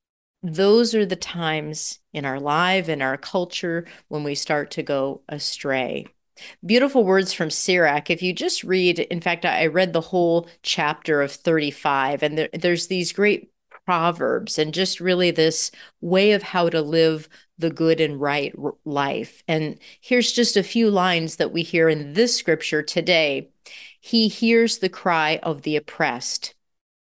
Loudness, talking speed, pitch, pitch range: -21 LUFS, 160 wpm, 170 Hz, 155-185 Hz